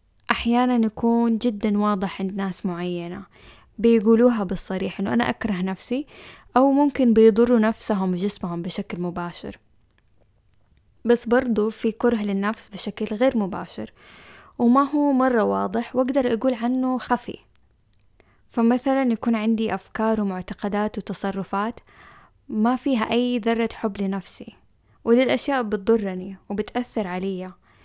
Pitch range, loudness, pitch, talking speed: 195-240 Hz, -22 LUFS, 220 Hz, 110 wpm